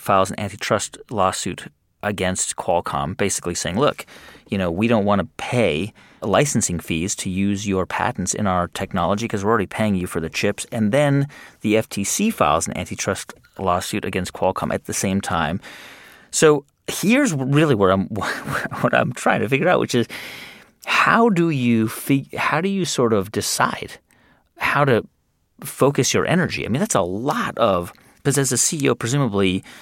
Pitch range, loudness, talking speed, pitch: 95-140 Hz, -20 LUFS, 170 wpm, 110 Hz